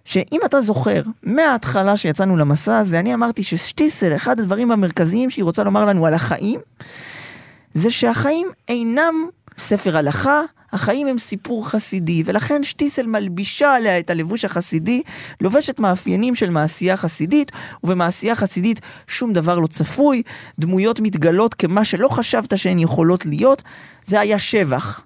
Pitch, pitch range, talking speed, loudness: 205 Hz, 170-235 Hz, 135 wpm, -18 LUFS